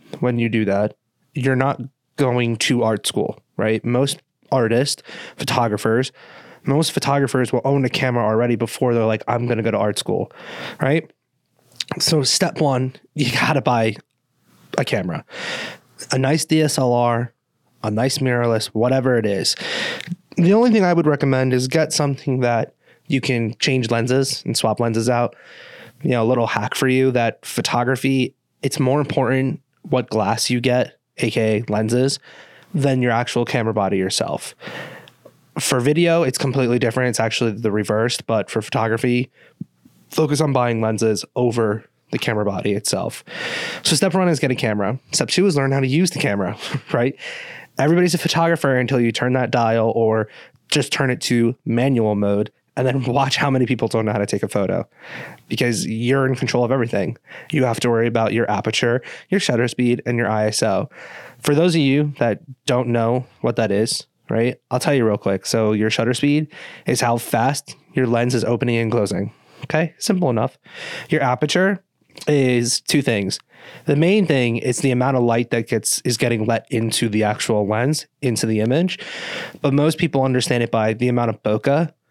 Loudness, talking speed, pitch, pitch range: -19 LUFS, 180 wpm, 125 Hz, 115-140 Hz